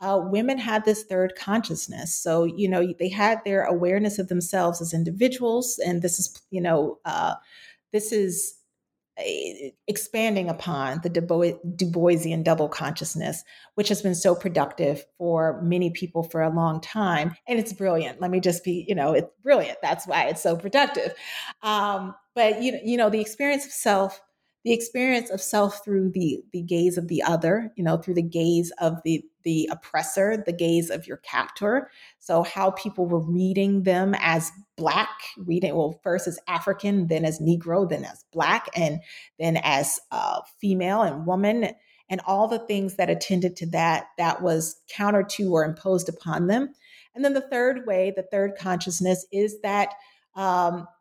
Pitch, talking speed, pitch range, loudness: 185 Hz, 175 wpm, 170-210 Hz, -25 LUFS